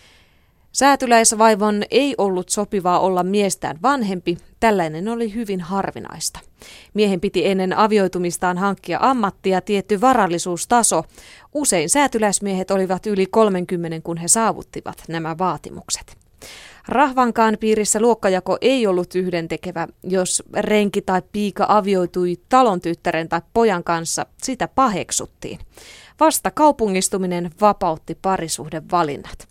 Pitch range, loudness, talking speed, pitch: 175-220 Hz, -19 LUFS, 105 wpm, 195 Hz